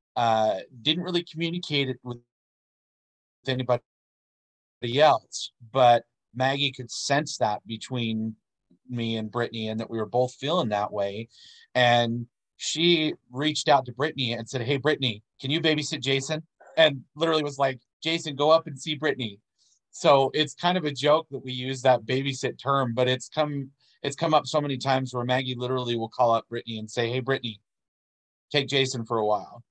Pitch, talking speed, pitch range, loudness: 130 Hz, 175 wpm, 120-150 Hz, -26 LUFS